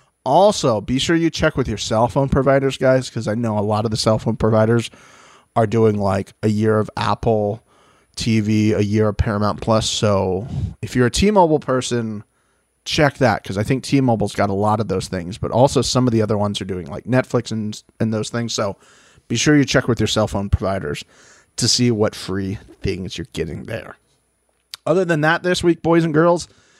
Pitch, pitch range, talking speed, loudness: 115 Hz, 105-130 Hz, 215 wpm, -19 LUFS